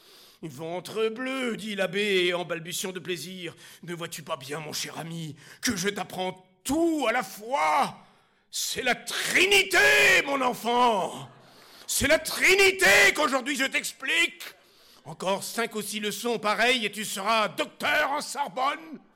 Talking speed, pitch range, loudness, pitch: 140 wpm, 180-270 Hz, -24 LUFS, 215 Hz